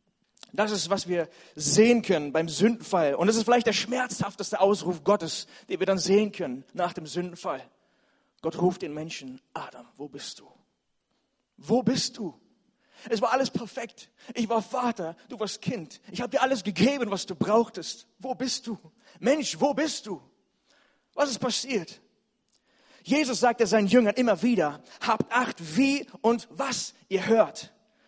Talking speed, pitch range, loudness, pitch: 160 wpm, 185-250 Hz, -26 LUFS, 215 Hz